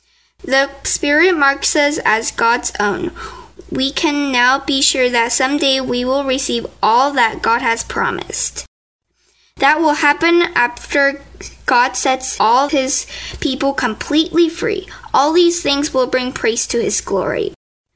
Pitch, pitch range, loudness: 290 Hz, 265-345 Hz, -15 LUFS